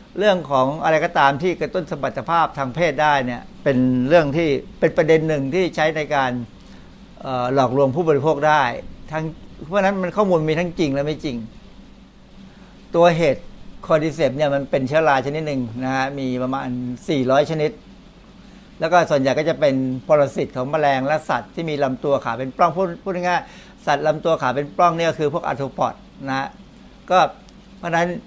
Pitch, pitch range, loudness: 155 Hz, 135-170 Hz, -20 LUFS